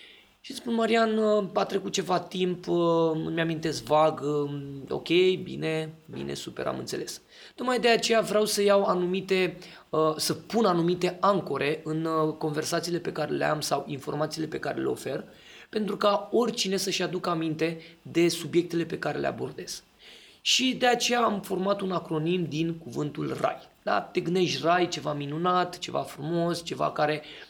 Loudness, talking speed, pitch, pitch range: -27 LUFS, 155 wpm, 175 Hz, 160-200 Hz